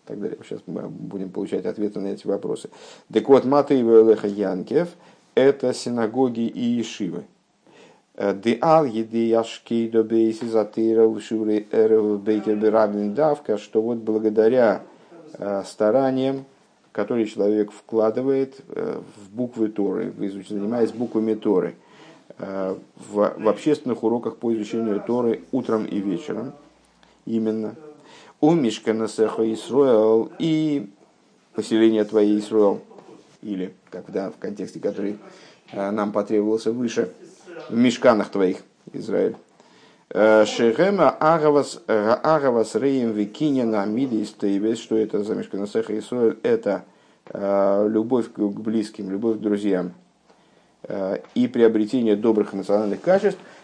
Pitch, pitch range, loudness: 110 Hz, 105-120 Hz, -22 LUFS